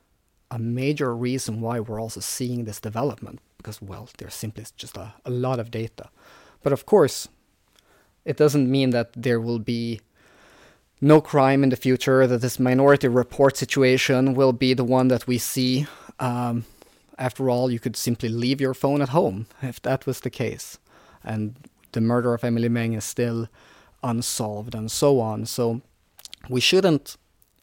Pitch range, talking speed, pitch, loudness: 115-130 Hz, 165 wpm, 125 Hz, -23 LUFS